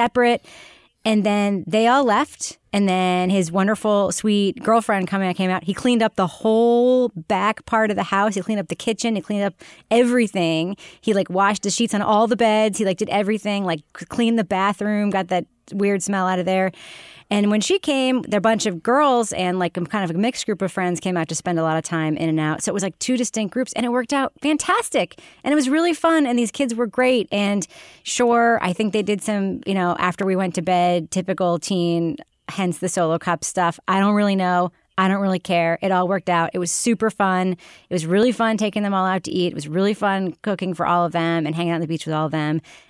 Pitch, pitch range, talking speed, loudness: 200 Hz, 180-220 Hz, 245 wpm, -20 LUFS